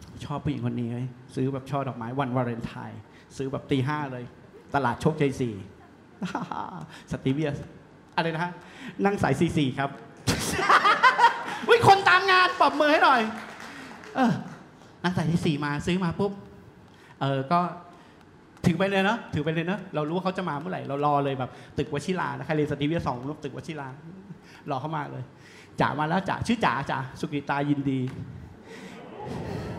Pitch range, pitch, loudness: 135-180 Hz, 150 Hz, -26 LUFS